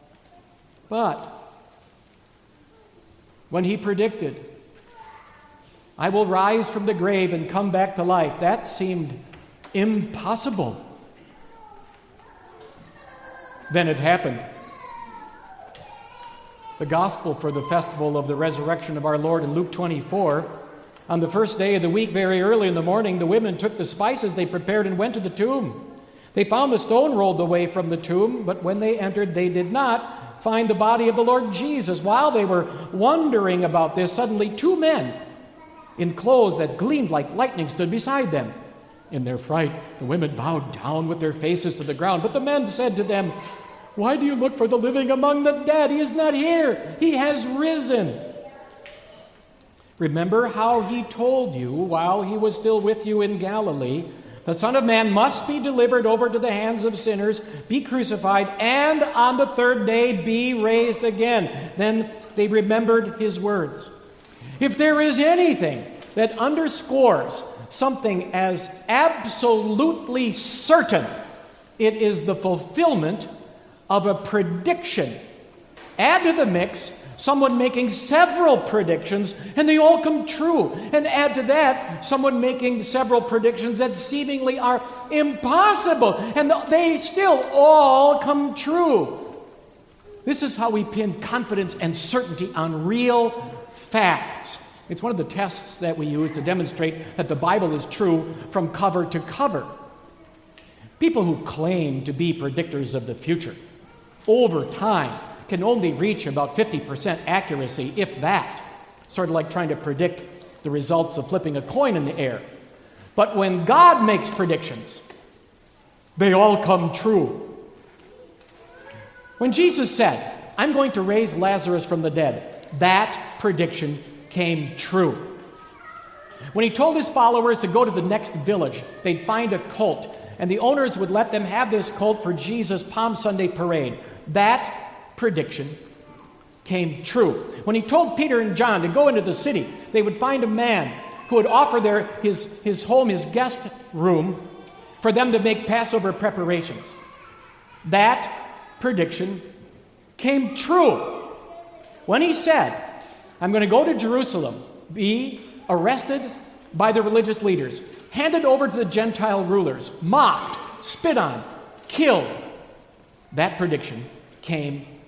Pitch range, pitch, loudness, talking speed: 175-255 Hz, 210 Hz, -21 LUFS, 150 wpm